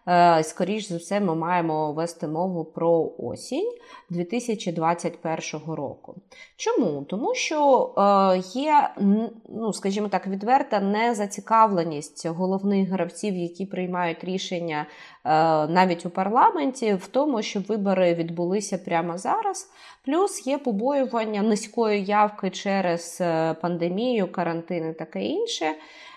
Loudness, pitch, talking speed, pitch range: -24 LUFS, 190 Hz, 105 wpm, 170-225 Hz